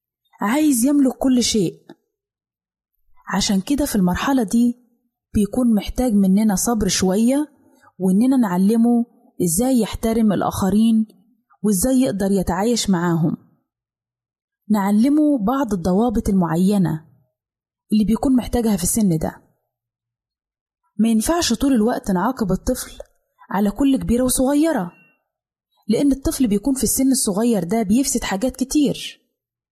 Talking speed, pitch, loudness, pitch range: 105 wpm, 225 Hz, -19 LUFS, 195-255 Hz